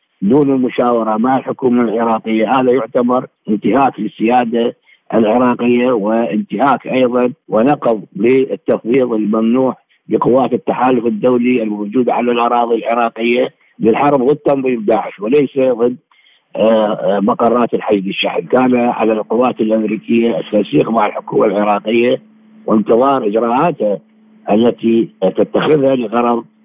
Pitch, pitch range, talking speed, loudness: 120 Hz, 110-125 Hz, 100 wpm, -14 LUFS